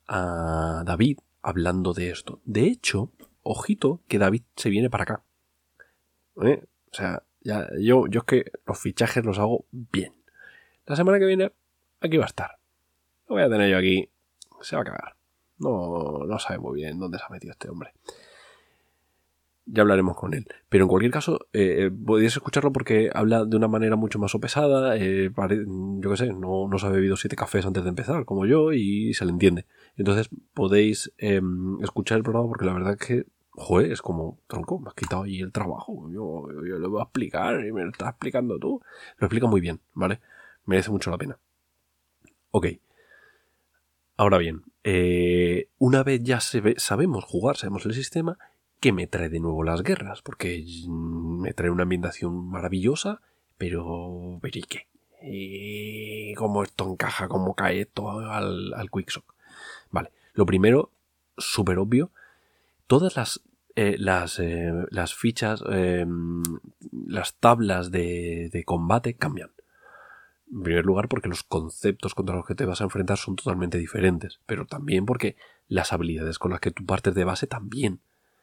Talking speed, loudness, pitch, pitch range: 170 wpm, -25 LUFS, 95 Hz, 90-110 Hz